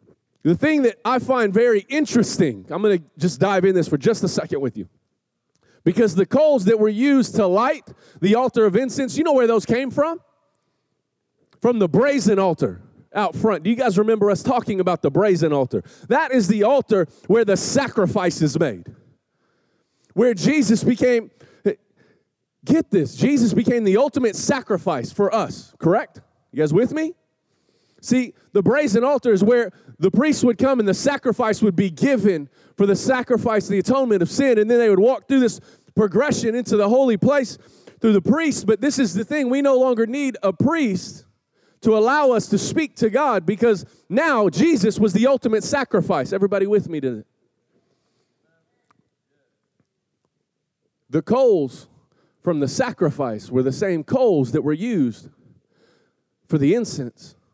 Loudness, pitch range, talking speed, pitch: -19 LUFS, 190-255 Hz, 170 wpm, 220 Hz